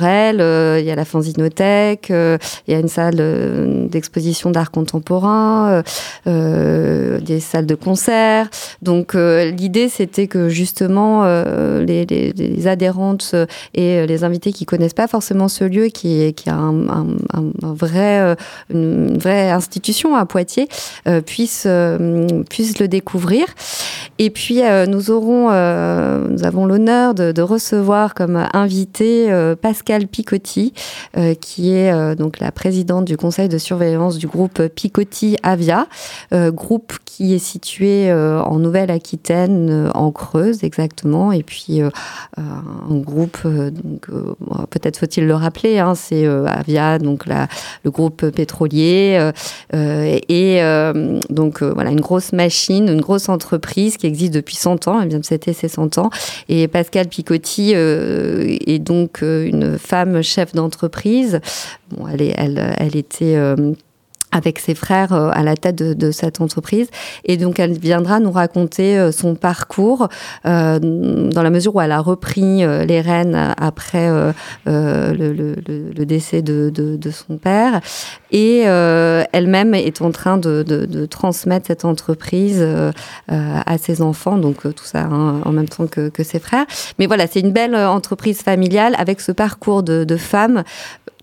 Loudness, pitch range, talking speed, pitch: -16 LUFS, 160-195 Hz, 155 wpm, 175 Hz